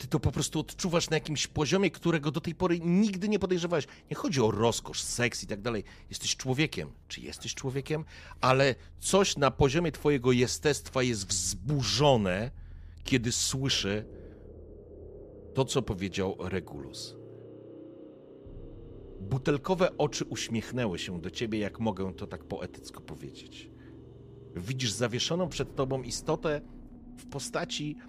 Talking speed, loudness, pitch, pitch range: 130 wpm, -30 LUFS, 125 Hz, 100-150 Hz